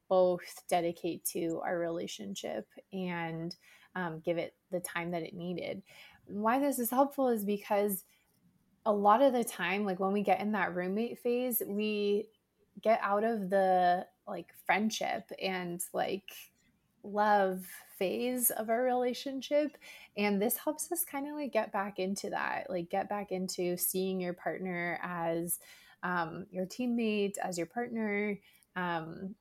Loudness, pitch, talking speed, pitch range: -33 LUFS, 195 Hz, 150 wpm, 180-225 Hz